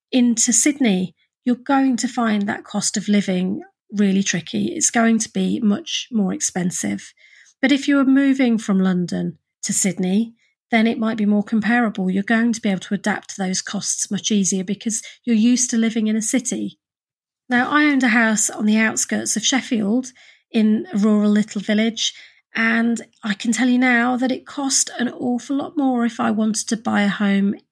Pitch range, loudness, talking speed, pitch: 205-245 Hz, -19 LUFS, 195 wpm, 225 Hz